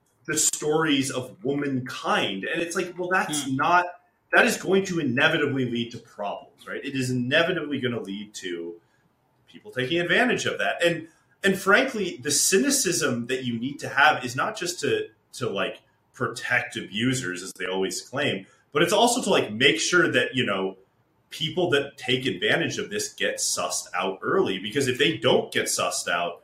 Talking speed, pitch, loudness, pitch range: 180 wpm, 140 Hz, -24 LUFS, 125-175 Hz